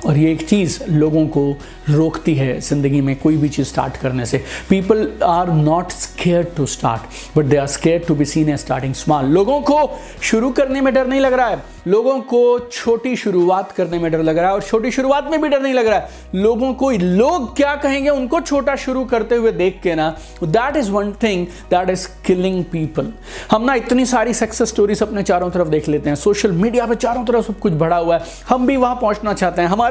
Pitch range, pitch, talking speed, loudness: 160-245 Hz, 190 Hz, 225 wpm, -17 LUFS